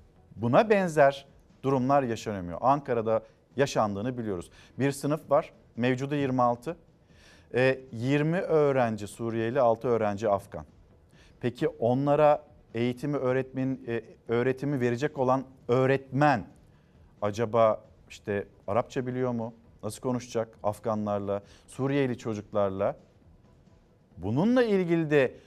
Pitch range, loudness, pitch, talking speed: 110-140 Hz, -28 LUFS, 125 Hz, 90 wpm